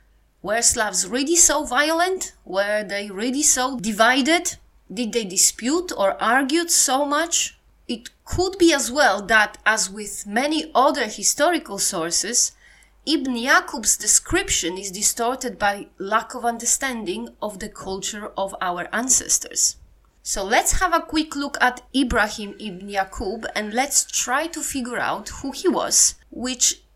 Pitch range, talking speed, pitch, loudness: 210-295 Hz, 140 wpm, 245 Hz, -20 LUFS